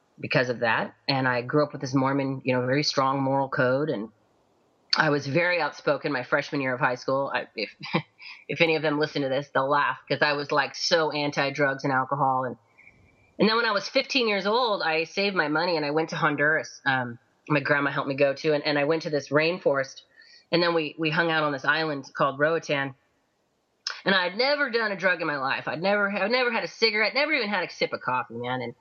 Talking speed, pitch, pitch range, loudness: 240 wpm, 145 Hz, 135-165 Hz, -25 LUFS